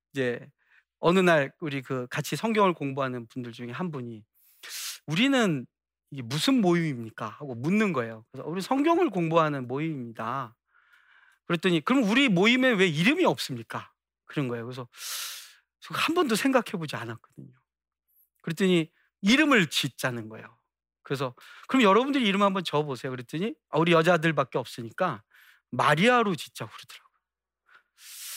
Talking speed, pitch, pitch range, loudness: 335 characters per minute, 155 Hz, 125-200 Hz, -26 LUFS